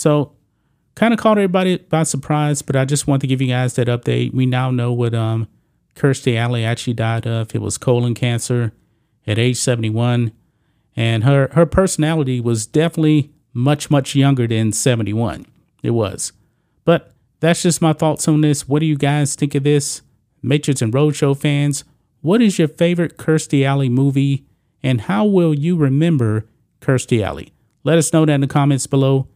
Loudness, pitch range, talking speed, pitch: -17 LUFS, 120-150 Hz, 180 wpm, 140 Hz